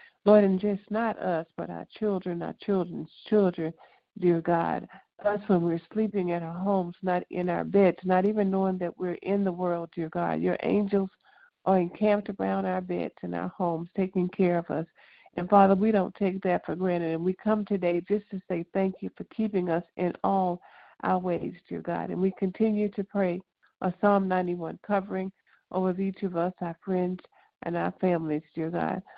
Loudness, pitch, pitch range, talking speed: -28 LUFS, 185 Hz, 175-200 Hz, 195 wpm